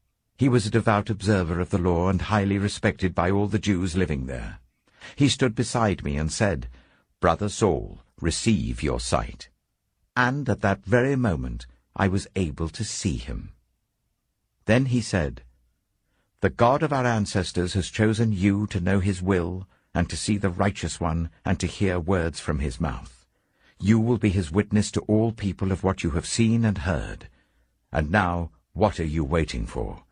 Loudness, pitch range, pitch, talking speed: -25 LUFS, 85-110 Hz, 95 Hz, 175 wpm